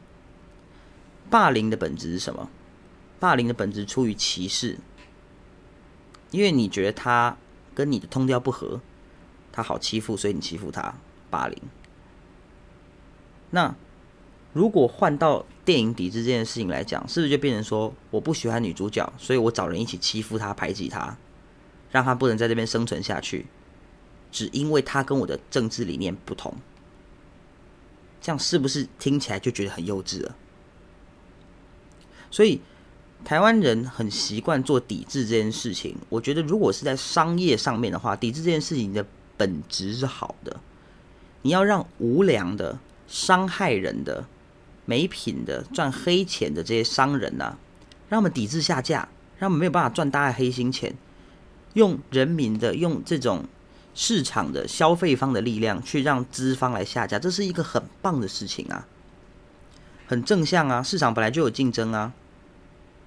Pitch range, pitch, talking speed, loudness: 100-140 Hz, 120 Hz, 240 characters per minute, -24 LUFS